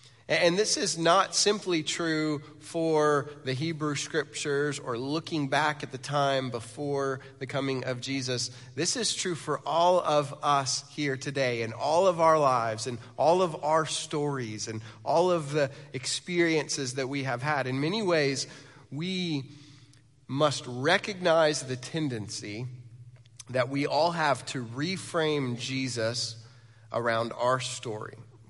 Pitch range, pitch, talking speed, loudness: 125-155 Hz, 140 Hz, 140 wpm, -28 LUFS